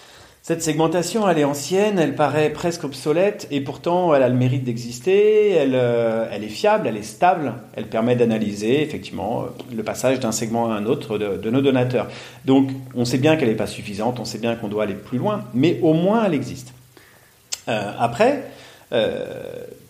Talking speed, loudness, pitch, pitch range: 190 wpm, -20 LUFS, 135 Hz, 120-175 Hz